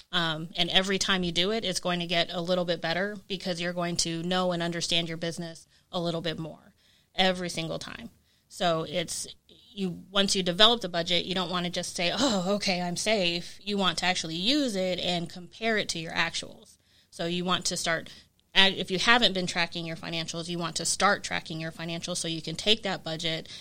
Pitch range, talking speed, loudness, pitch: 170-190 Hz, 220 wpm, -27 LUFS, 175 Hz